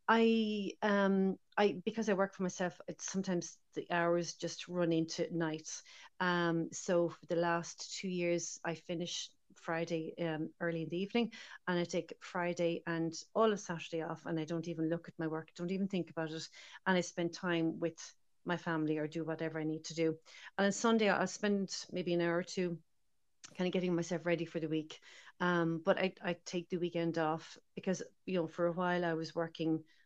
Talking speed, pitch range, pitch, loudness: 205 wpm, 165-185 Hz, 170 Hz, -36 LUFS